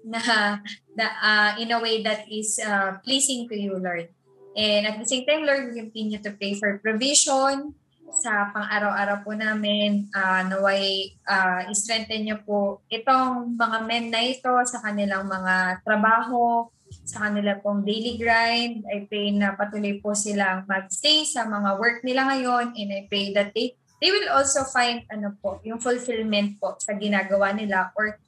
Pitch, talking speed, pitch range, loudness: 215 Hz, 170 wpm, 200-235 Hz, -23 LUFS